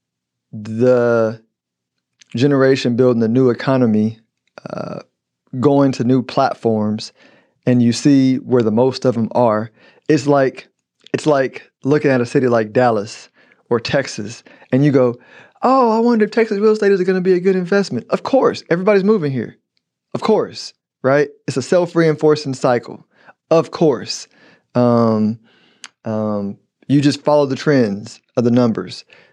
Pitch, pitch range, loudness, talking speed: 130 Hz, 115-145 Hz, -16 LUFS, 150 wpm